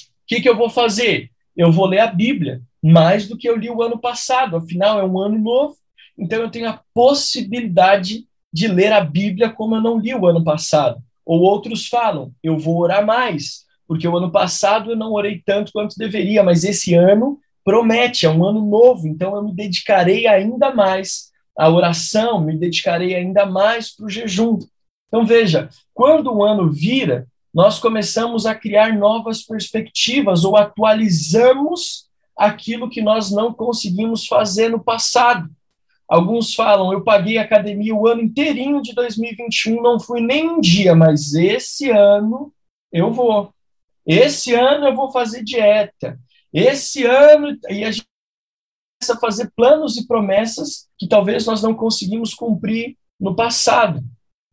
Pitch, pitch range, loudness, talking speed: 220 Hz, 190-235 Hz, -16 LUFS, 165 wpm